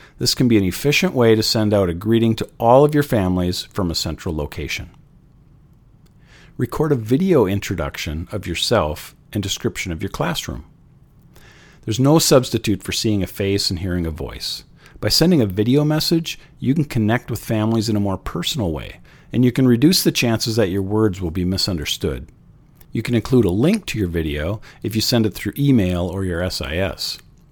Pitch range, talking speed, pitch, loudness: 95-135 Hz, 190 wpm, 110 Hz, -19 LUFS